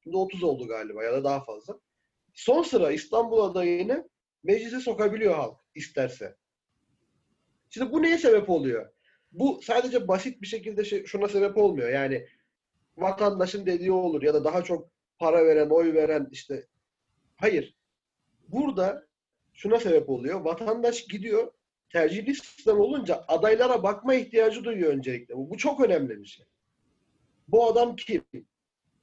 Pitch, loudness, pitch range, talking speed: 205 Hz, -26 LUFS, 165-245 Hz, 135 wpm